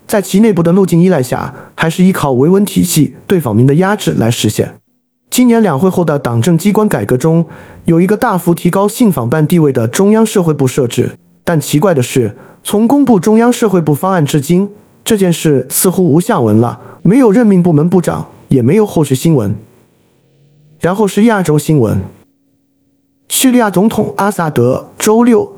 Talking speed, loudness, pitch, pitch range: 275 characters per minute, -11 LUFS, 170 Hz, 140-205 Hz